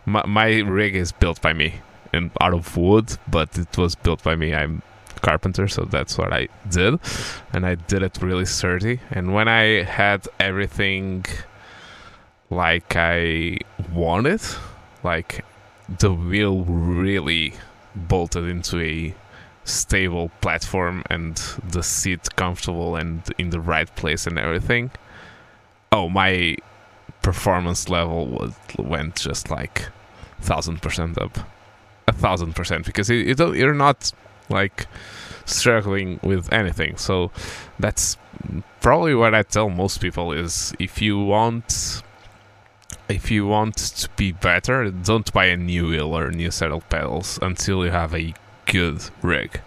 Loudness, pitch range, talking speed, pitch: -21 LUFS, 85-105 Hz, 140 wpm, 95 Hz